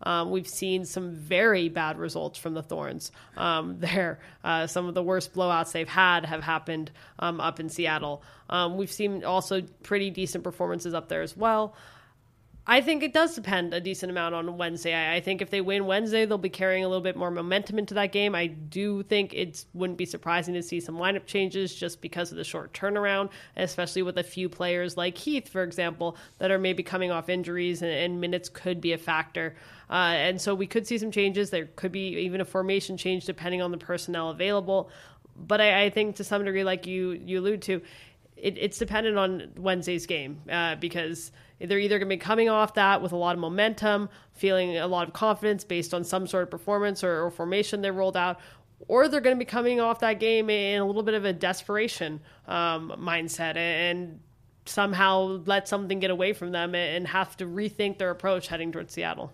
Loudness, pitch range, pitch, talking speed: -27 LUFS, 170-200 Hz, 185 Hz, 210 wpm